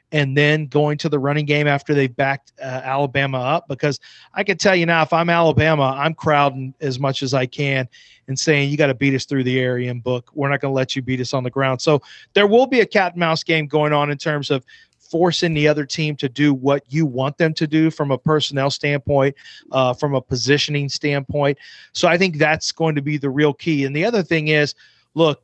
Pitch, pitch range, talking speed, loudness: 145 Hz, 135-160 Hz, 245 wpm, -19 LUFS